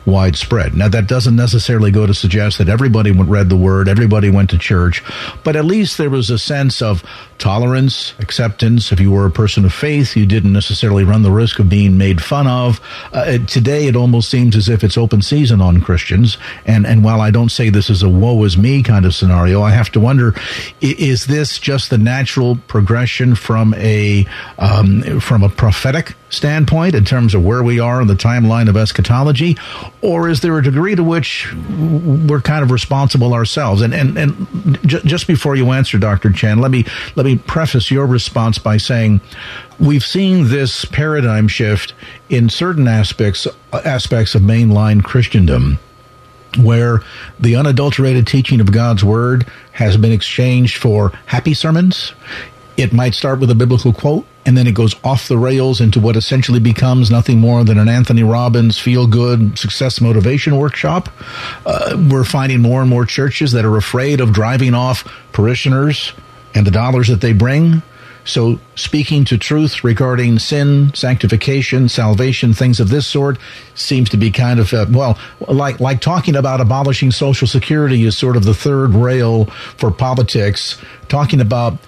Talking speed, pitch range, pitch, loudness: 175 wpm, 110-135 Hz, 120 Hz, -12 LUFS